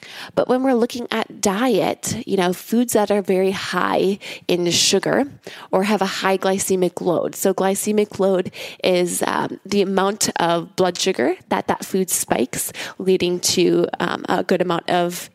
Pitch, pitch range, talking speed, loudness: 190 Hz, 180-210 Hz, 165 wpm, -20 LUFS